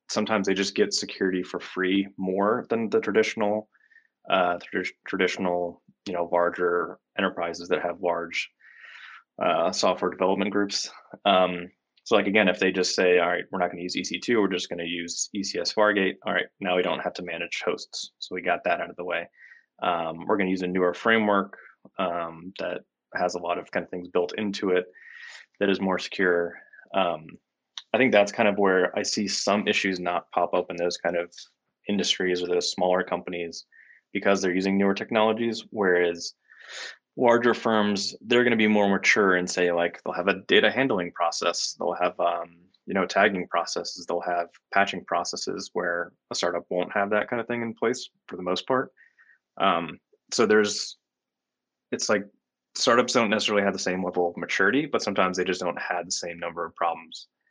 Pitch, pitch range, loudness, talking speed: 90 Hz, 85-100 Hz, -25 LUFS, 195 wpm